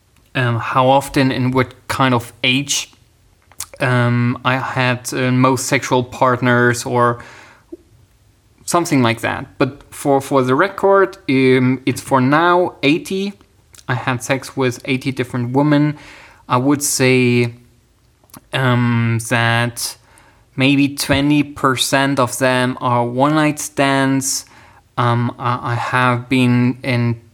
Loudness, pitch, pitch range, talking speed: -16 LUFS, 125 Hz, 120-135 Hz, 120 wpm